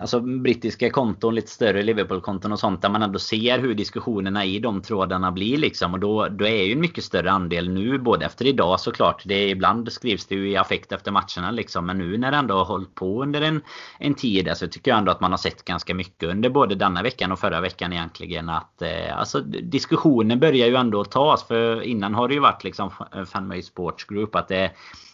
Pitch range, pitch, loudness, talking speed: 95-115 Hz, 105 Hz, -22 LUFS, 220 wpm